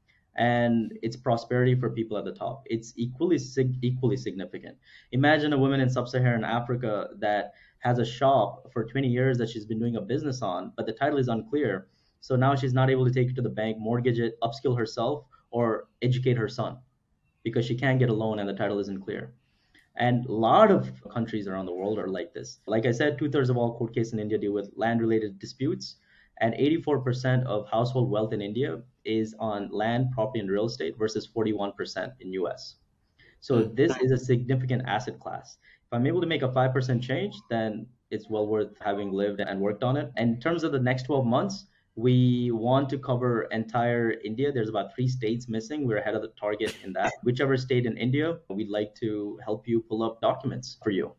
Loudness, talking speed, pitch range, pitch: -27 LUFS, 205 wpm, 110-130 Hz, 120 Hz